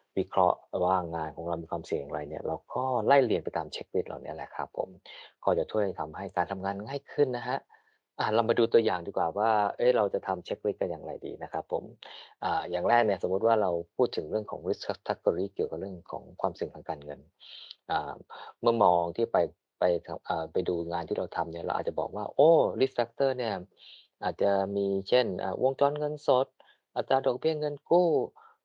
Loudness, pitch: -29 LUFS, 120 Hz